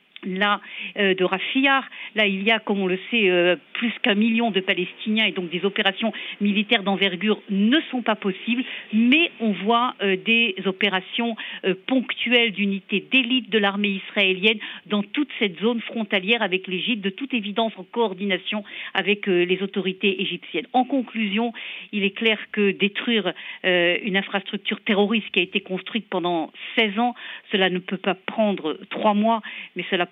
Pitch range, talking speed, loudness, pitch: 190-230 Hz, 170 wpm, -22 LUFS, 205 Hz